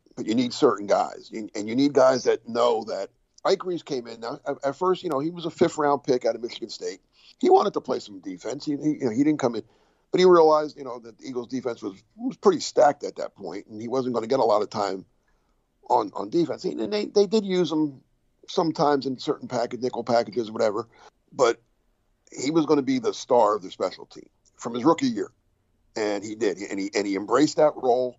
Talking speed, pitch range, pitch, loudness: 240 wpm, 125-185 Hz, 145 Hz, -24 LUFS